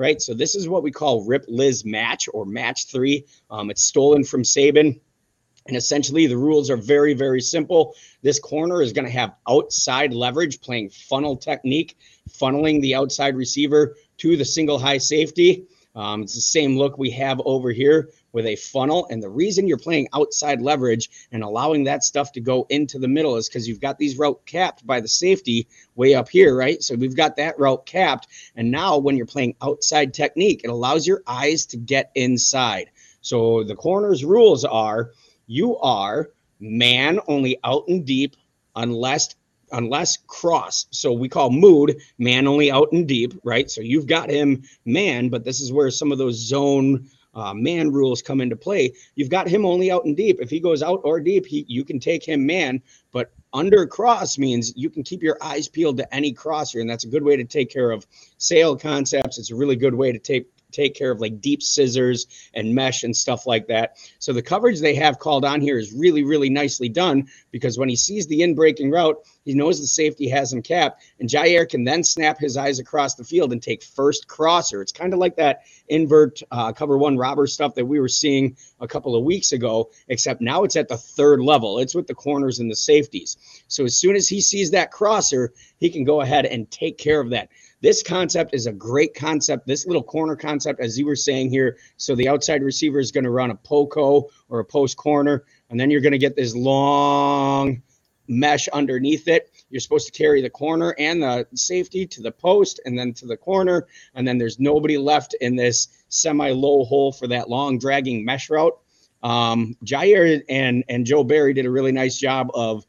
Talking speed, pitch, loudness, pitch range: 205 wpm, 140 Hz, -20 LUFS, 125-155 Hz